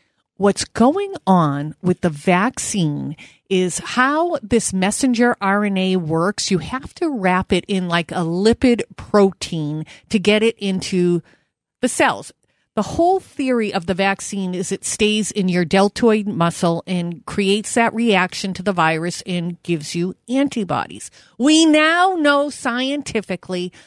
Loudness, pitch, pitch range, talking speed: -18 LUFS, 195 Hz, 180-235 Hz, 140 wpm